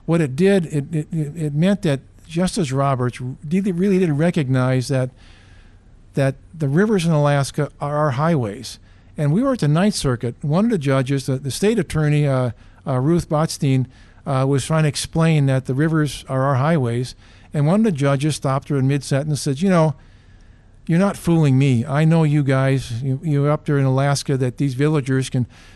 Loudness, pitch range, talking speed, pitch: -19 LUFS, 130-160 Hz, 195 wpm, 140 Hz